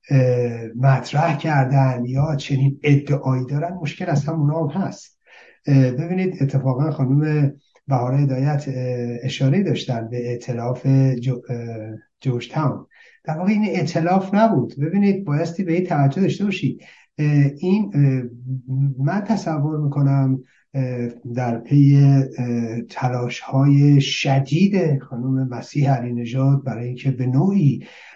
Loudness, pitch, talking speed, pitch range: -20 LUFS, 135 Hz, 110 wpm, 130-155 Hz